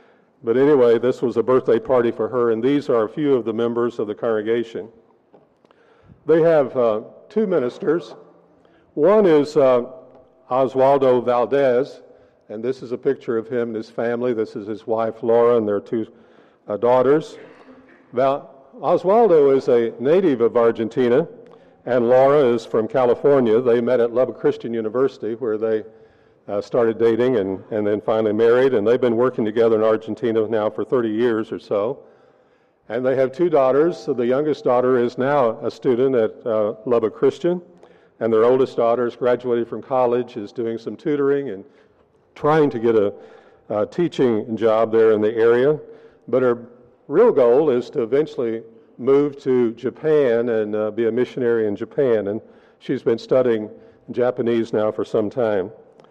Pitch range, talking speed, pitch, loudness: 115-140 Hz, 170 wpm, 125 Hz, -19 LUFS